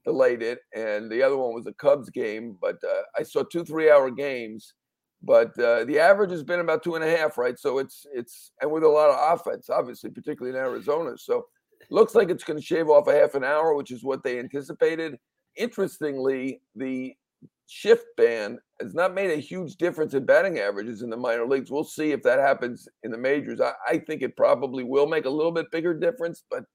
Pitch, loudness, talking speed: 165 Hz, -24 LUFS, 220 wpm